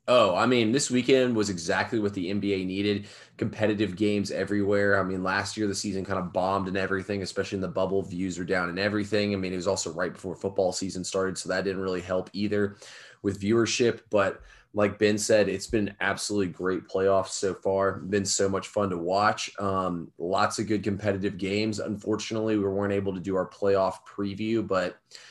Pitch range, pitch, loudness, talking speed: 95-105 Hz, 100 Hz, -27 LUFS, 205 wpm